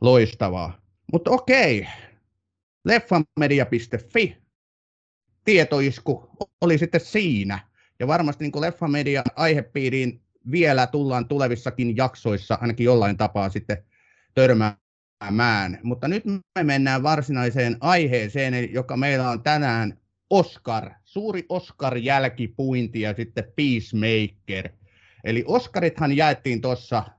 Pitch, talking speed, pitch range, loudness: 125 Hz, 95 wpm, 110-150 Hz, -22 LUFS